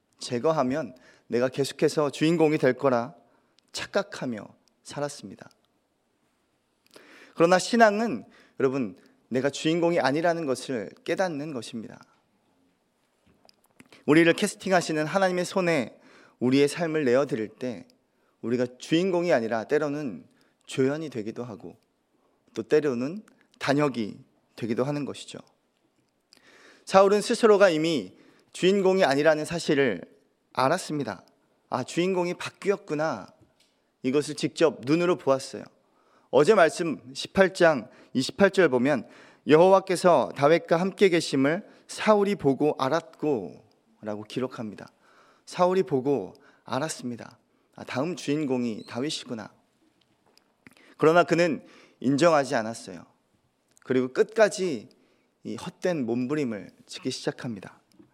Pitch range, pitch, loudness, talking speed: 130-180 Hz, 155 Hz, -25 LUFS, 260 characters per minute